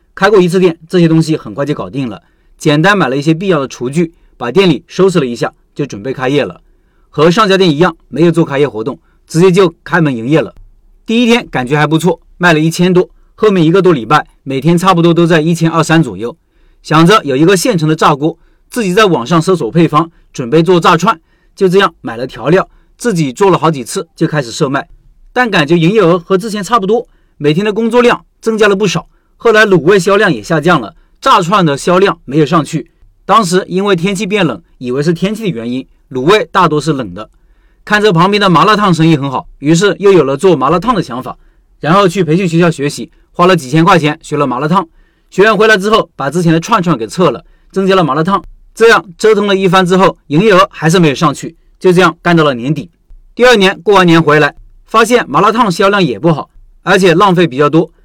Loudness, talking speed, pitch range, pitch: -10 LUFS, 330 characters per minute, 155-195 Hz, 170 Hz